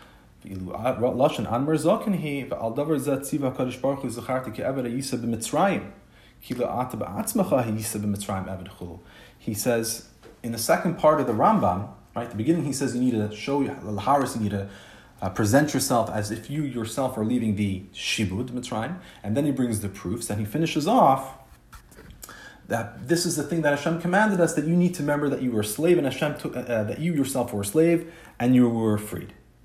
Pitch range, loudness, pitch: 110-145 Hz, -25 LUFS, 125 Hz